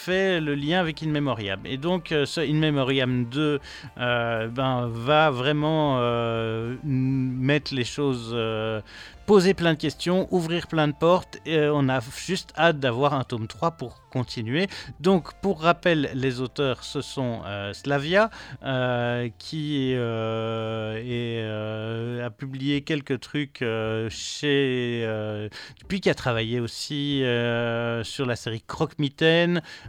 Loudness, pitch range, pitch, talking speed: -25 LUFS, 120-155 Hz, 135 Hz, 145 wpm